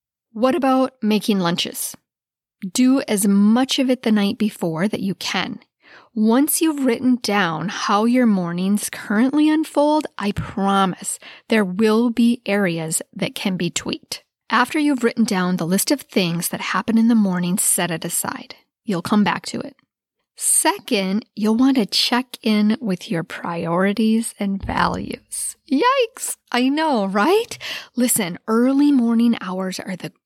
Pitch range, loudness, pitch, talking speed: 195-255 Hz, -19 LUFS, 220 Hz, 150 wpm